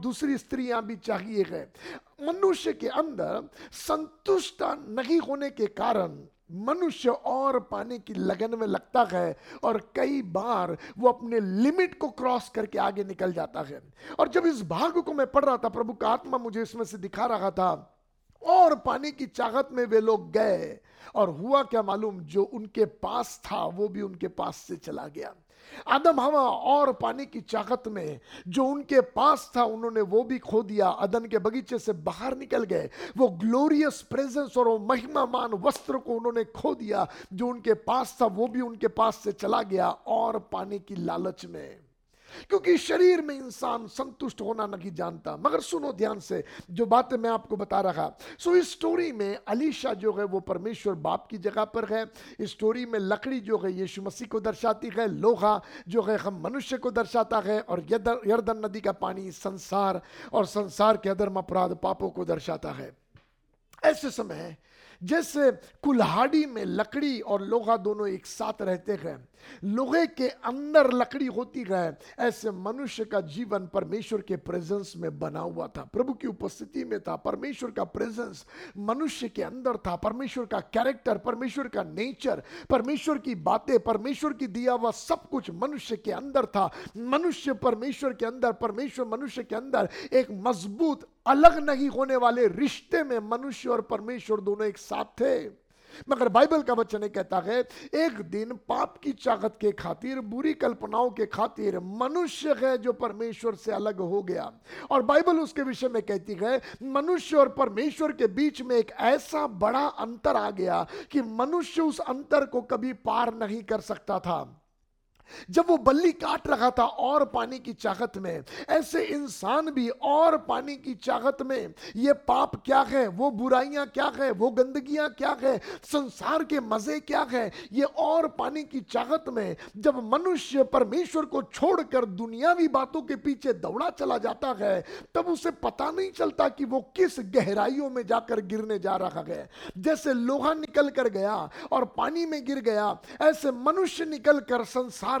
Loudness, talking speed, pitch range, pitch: -28 LUFS, 165 wpm, 215-280 Hz, 245 Hz